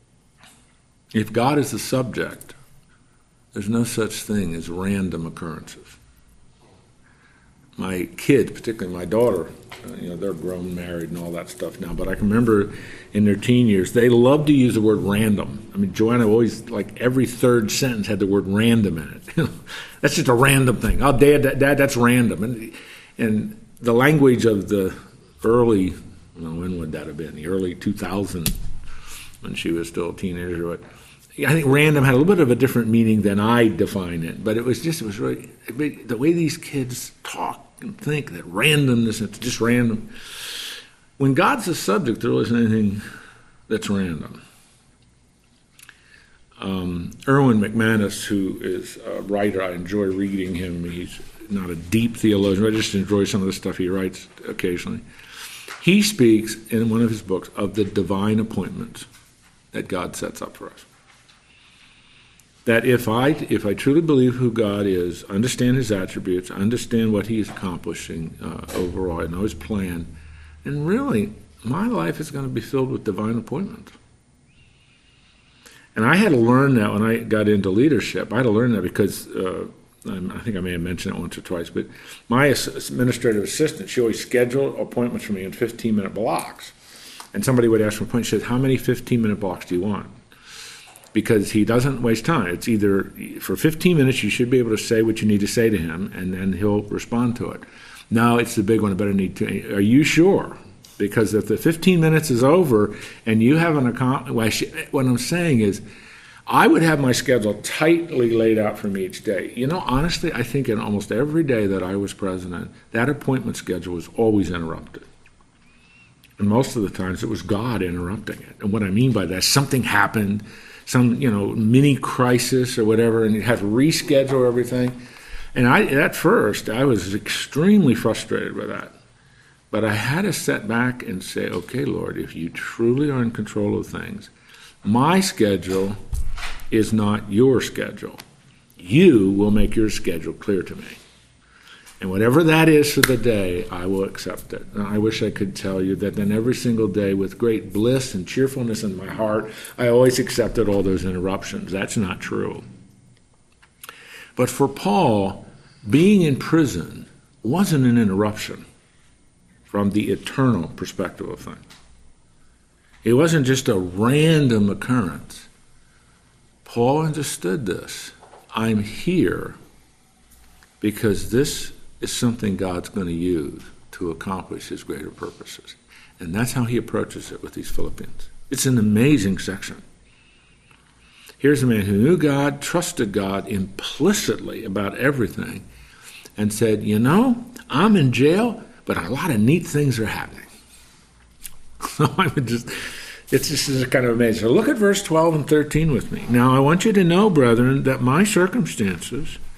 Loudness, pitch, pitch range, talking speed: -20 LUFS, 110 Hz, 100-130 Hz, 170 wpm